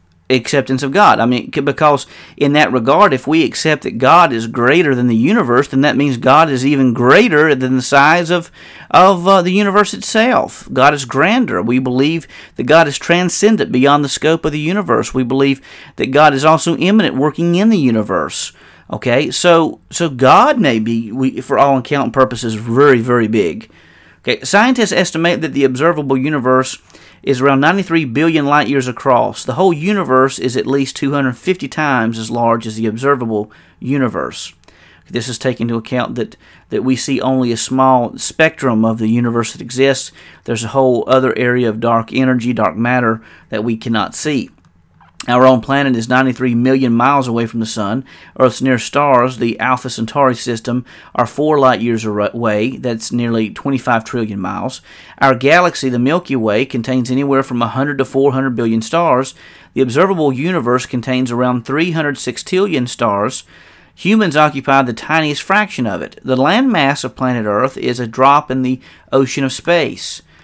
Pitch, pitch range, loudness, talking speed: 130 Hz, 120-150 Hz, -13 LUFS, 175 wpm